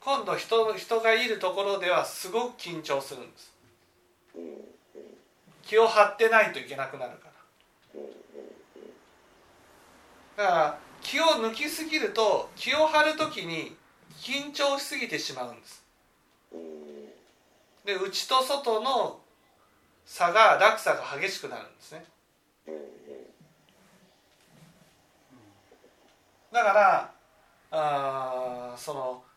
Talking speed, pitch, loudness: 190 characters per minute, 225 Hz, -26 LUFS